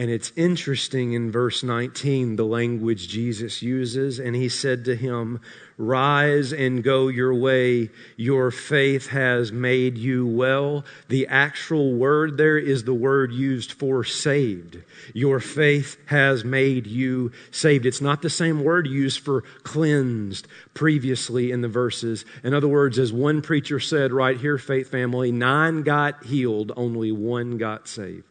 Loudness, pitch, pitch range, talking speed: -22 LUFS, 130 Hz, 120-140 Hz, 155 wpm